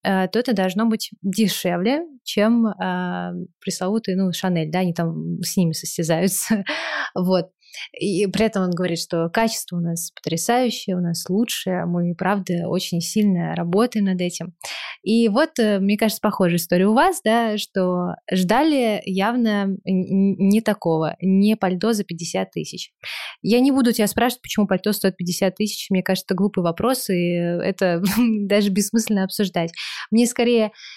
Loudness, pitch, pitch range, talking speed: -21 LUFS, 195 Hz, 175-215 Hz, 155 wpm